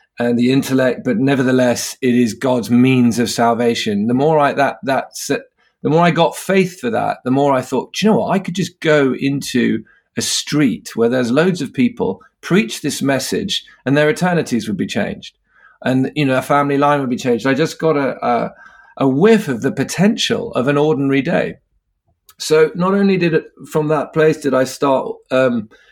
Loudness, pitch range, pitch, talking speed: -16 LUFS, 125-160 Hz, 140 Hz, 205 wpm